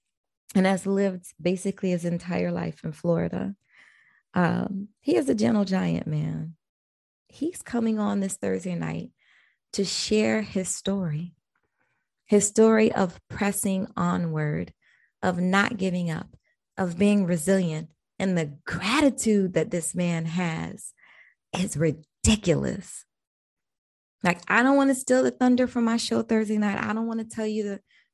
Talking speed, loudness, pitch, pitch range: 145 wpm, -25 LUFS, 190 Hz, 170-215 Hz